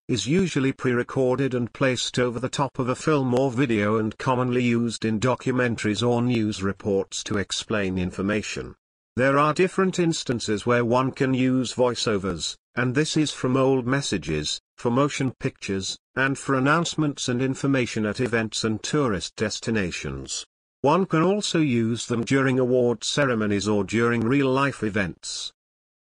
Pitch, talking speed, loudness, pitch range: 125 Hz, 150 wpm, -24 LUFS, 110-135 Hz